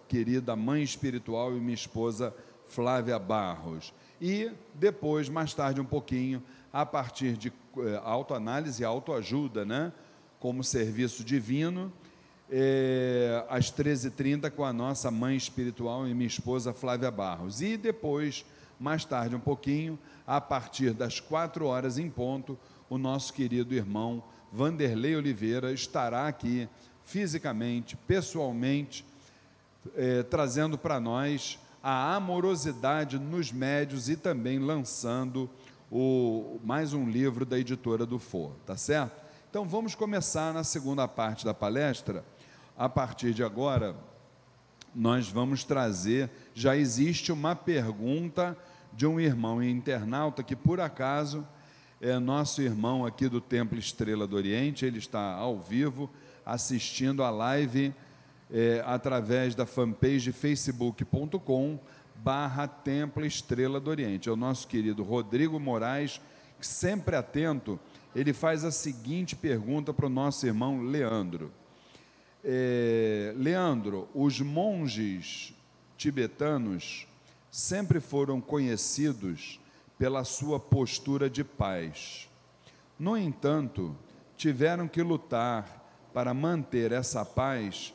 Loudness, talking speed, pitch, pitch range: -31 LUFS, 120 wpm, 130 Hz, 120-145 Hz